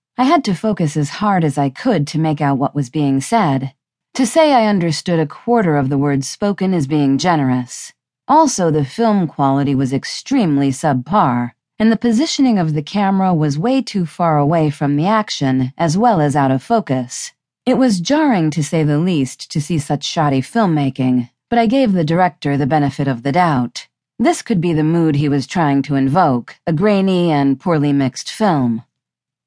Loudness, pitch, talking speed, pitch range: -16 LUFS, 155 Hz, 190 wpm, 140-205 Hz